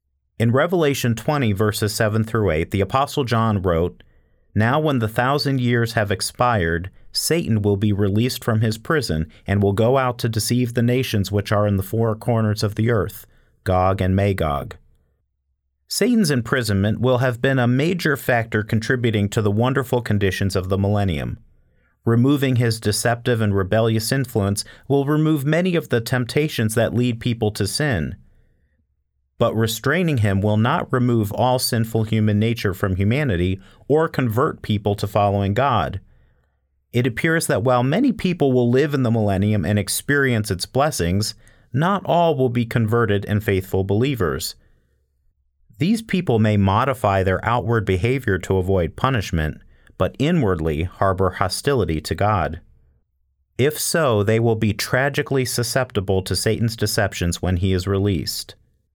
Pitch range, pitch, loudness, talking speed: 95-125 Hz, 110 Hz, -20 LUFS, 150 wpm